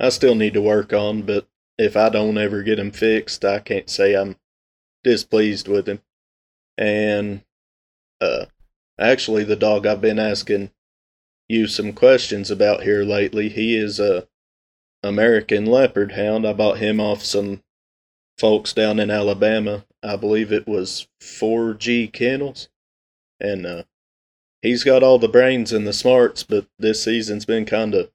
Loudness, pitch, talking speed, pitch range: -19 LUFS, 105 Hz, 155 wpm, 100-110 Hz